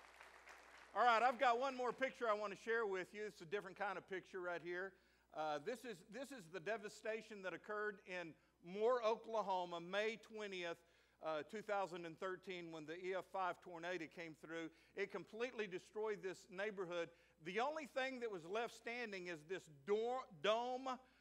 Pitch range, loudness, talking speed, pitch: 175-225 Hz, -45 LUFS, 165 wpm, 200 Hz